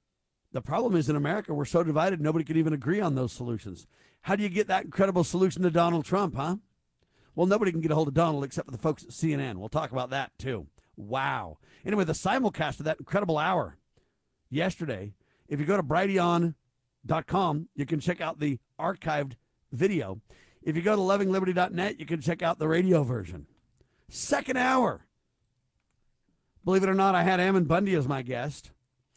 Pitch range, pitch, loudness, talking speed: 135-185 Hz, 160 Hz, -28 LUFS, 185 wpm